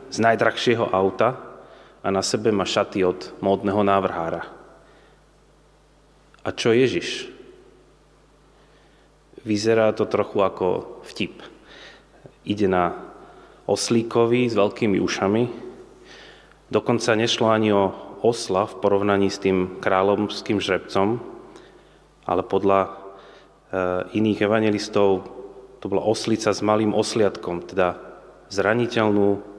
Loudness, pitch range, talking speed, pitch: -22 LUFS, 95-110 Hz, 95 wpm, 100 Hz